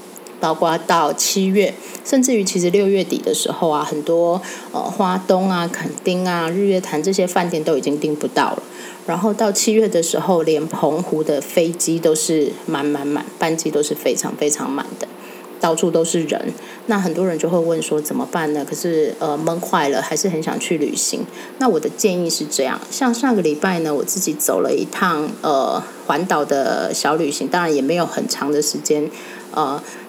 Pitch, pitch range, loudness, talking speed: 170 Hz, 155-190 Hz, -19 LUFS, 275 characters per minute